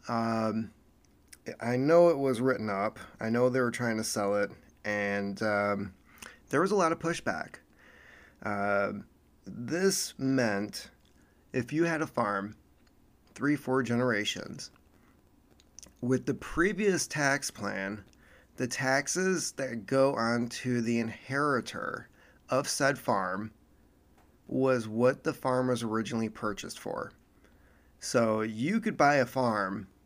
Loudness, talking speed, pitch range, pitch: -30 LUFS, 125 wpm, 100-130 Hz, 115 Hz